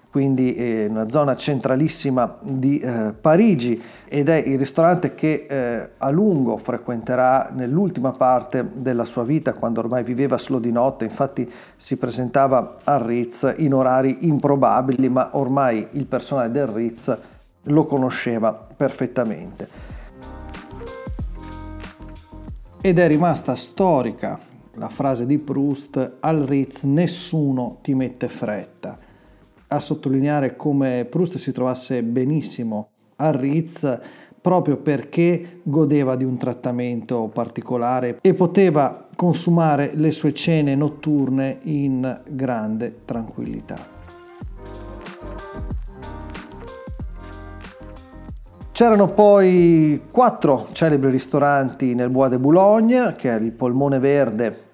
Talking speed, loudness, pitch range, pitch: 110 wpm, -20 LUFS, 120-150 Hz, 135 Hz